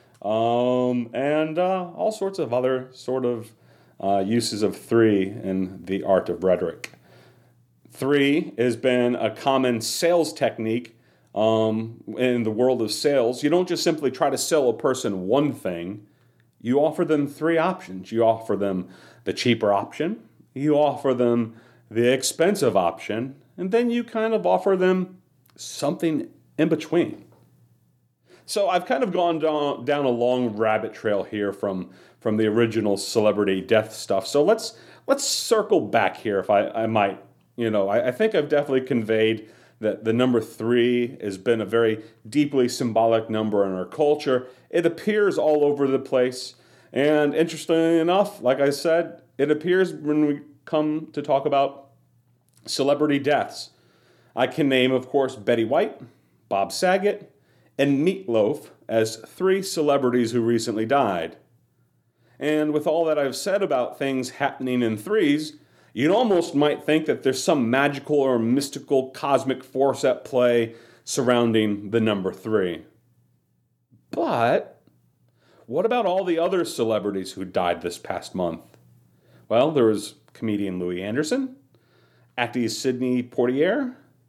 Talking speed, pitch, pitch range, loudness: 150 wpm, 125 Hz, 110-150 Hz, -23 LUFS